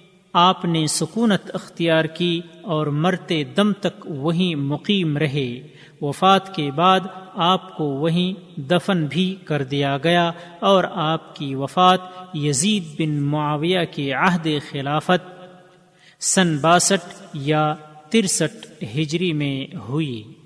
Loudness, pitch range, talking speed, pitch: -20 LUFS, 150-185 Hz, 115 wpm, 170 Hz